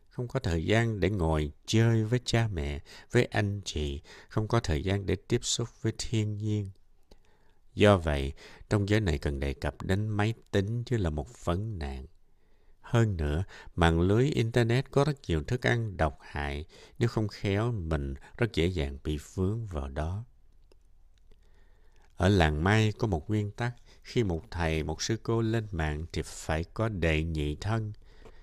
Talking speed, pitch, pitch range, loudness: 175 wpm, 100 Hz, 80-115 Hz, -30 LUFS